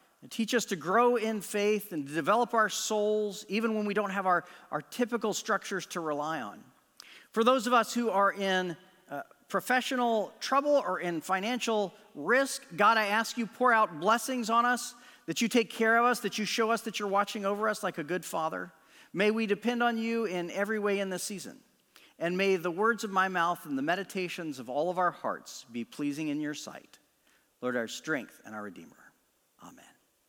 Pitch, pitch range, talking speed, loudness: 210 Hz, 185-230 Hz, 205 wpm, -30 LUFS